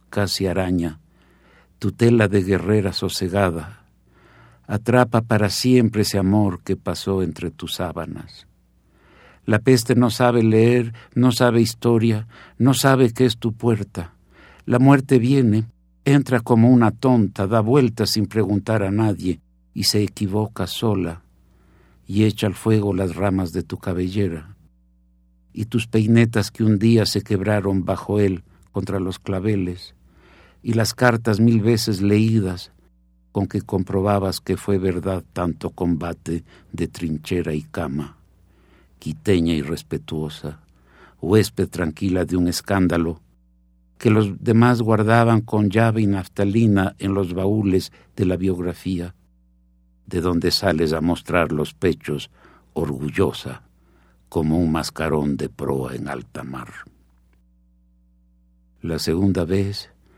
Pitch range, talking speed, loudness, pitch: 85-110 Hz, 130 wpm, -20 LUFS, 95 Hz